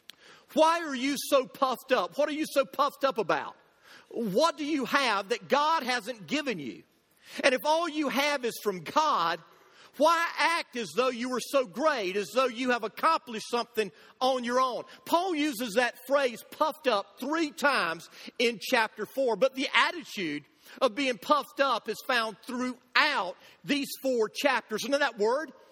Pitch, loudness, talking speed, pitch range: 265 Hz, -28 LUFS, 175 wpm, 240-295 Hz